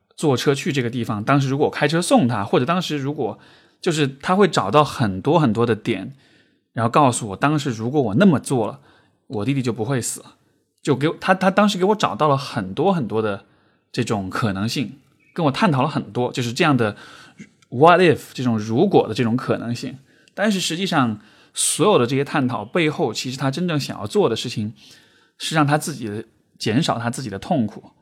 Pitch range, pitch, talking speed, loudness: 115-155 Hz, 135 Hz, 310 characters per minute, -20 LUFS